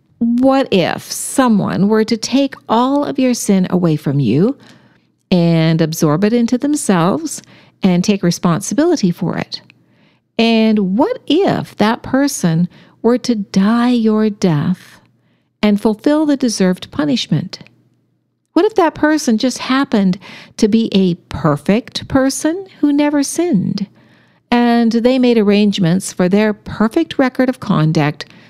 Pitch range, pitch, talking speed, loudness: 185-260 Hz, 220 Hz, 130 wpm, -15 LUFS